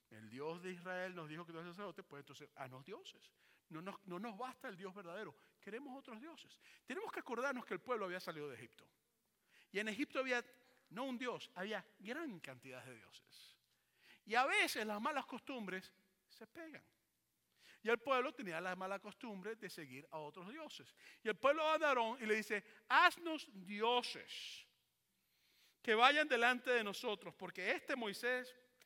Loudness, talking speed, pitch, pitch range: -40 LUFS, 180 wpm, 220 Hz, 185-255 Hz